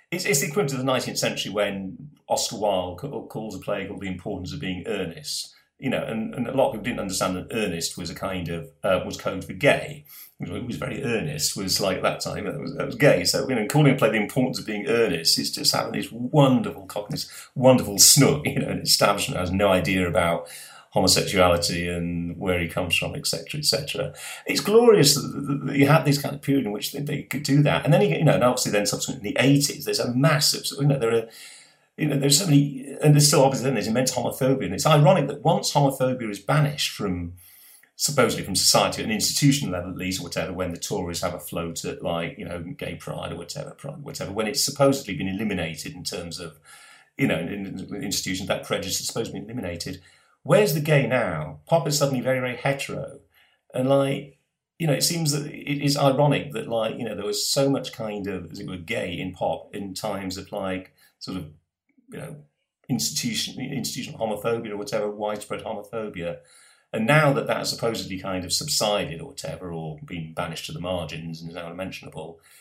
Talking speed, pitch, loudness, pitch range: 220 wpm, 125 Hz, -23 LUFS, 95-140 Hz